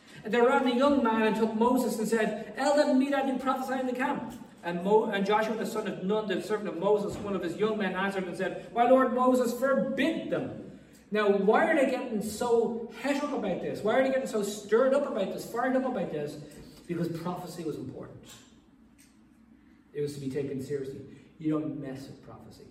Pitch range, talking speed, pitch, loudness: 185-260 Hz, 215 wpm, 220 Hz, -28 LUFS